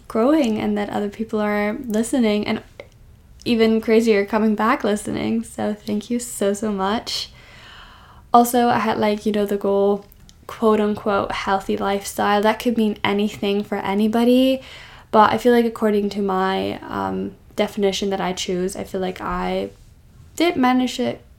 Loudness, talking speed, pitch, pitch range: -20 LUFS, 155 wpm, 210 Hz, 200-225 Hz